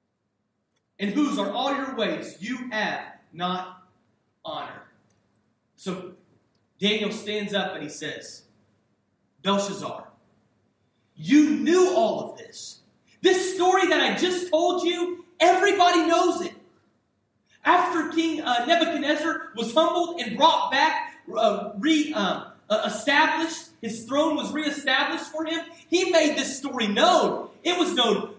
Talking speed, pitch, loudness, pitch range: 130 wpm, 295 Hz, -23 LUFS, 210-335 Hz